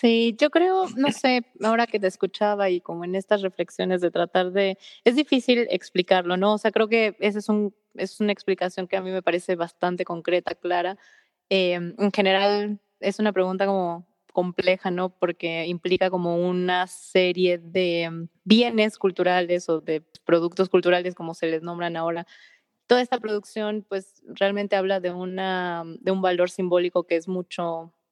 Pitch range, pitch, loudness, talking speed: 175-205 Hz, 185 Hz, -24 LUFS, 170 wpm